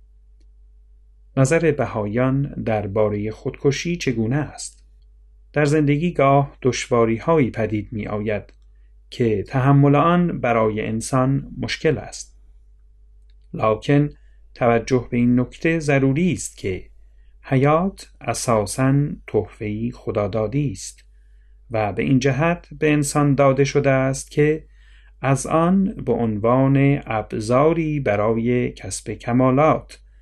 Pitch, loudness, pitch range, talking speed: 125 Hz, -20 LUFS, 105-145 Hz, 105 wpm